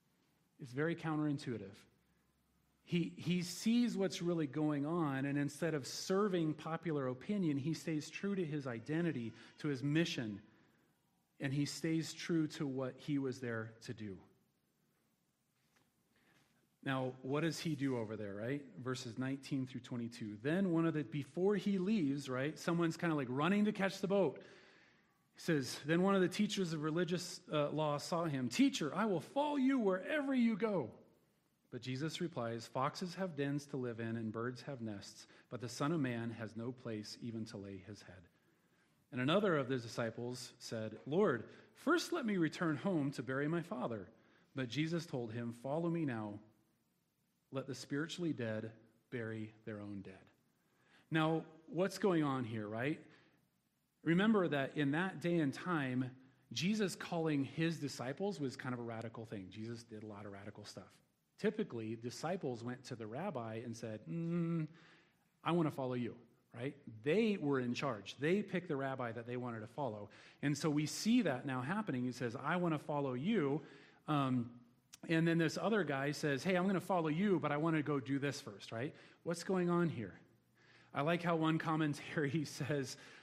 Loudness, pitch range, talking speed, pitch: -39 LUFS, 120-170 Hz, 180 wpm, 145 Hz